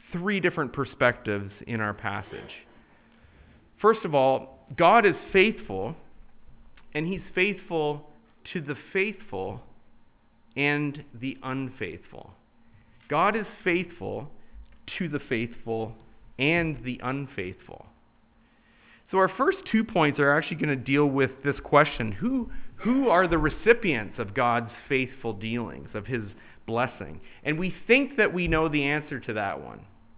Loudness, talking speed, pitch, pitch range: -26 LUFS, 130 wpm, 140 Hz, 115-175 Hz